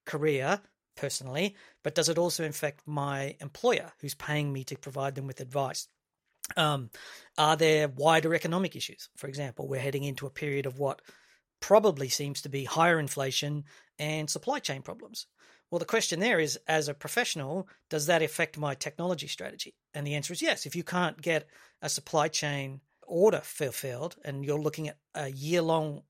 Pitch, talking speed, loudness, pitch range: 150 Hz, 175 wpm, -30 LUFS, 140-165 Hz